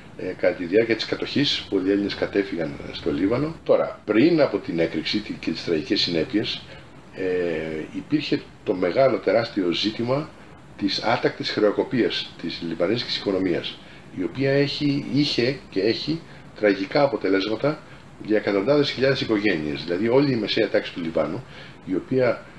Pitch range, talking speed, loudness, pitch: 95-140 Hz, 140 wpm, -23 LUFS, 115 Hz